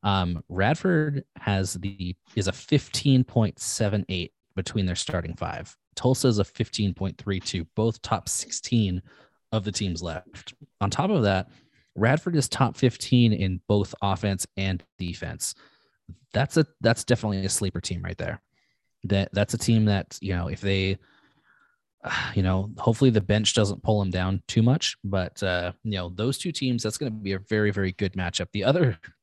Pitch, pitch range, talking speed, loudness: 105 Hz, 95-125 Hz, 170 wpm, -26 LUFS